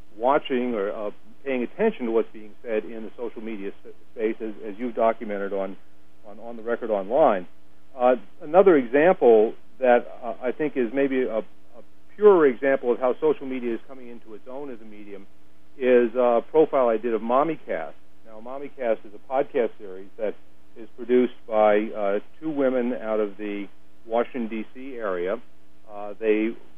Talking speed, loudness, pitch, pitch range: 180 wpm, -24 LUFS, 115 Hz, 100-125 Hz